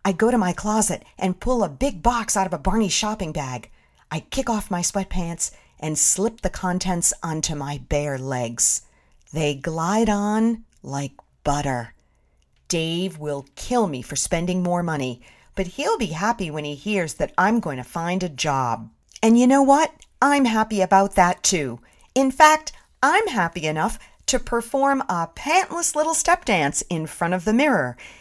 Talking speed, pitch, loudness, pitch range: 175 wpm, 185 Hz, -22 LUFS, 150-225 Hz